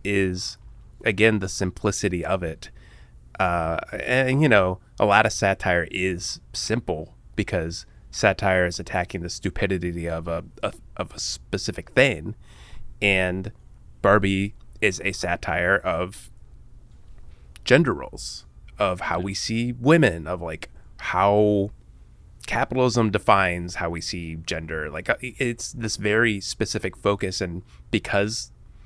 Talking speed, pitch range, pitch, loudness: 125 wpm, 90-110 Hz, 95 Hz, -24 LUFS